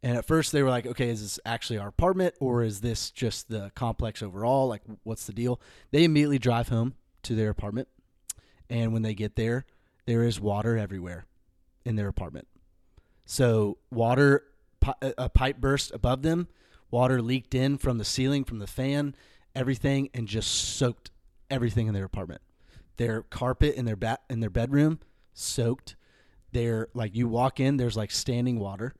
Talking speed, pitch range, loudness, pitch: 175 wpm, 110-130 Hz, -28 LUFS, 115 Hz